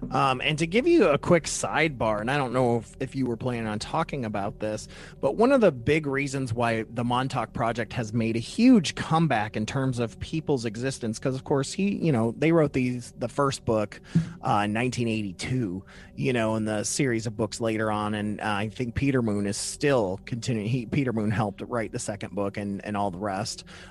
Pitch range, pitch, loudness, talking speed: 110-140 Hz, 120 Hz, -26 LUFS, 220 wpm